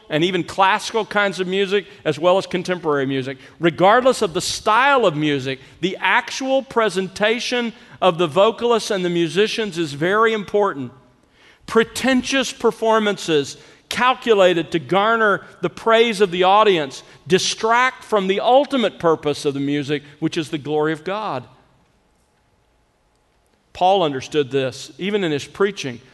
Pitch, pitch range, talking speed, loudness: 185 Hz, 155-220 Hz, 140 wpm, -19 LUFS